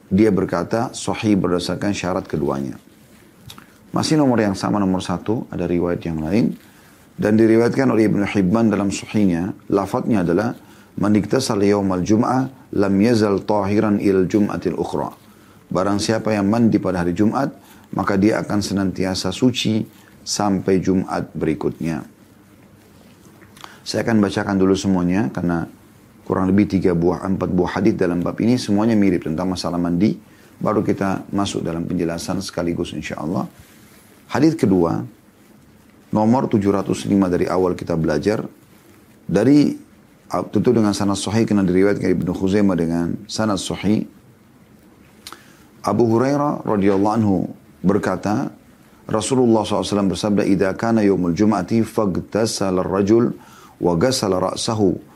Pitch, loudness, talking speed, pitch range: 100 Hz, -19 LUFS, 120 wpm, 90-110 Hz